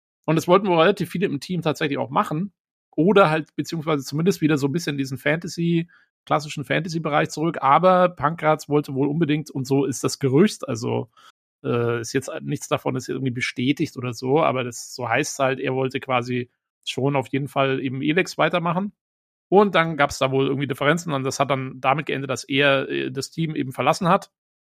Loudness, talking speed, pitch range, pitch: -22 LUFS, 200 wpm, 135-165 Hz, 145 Hz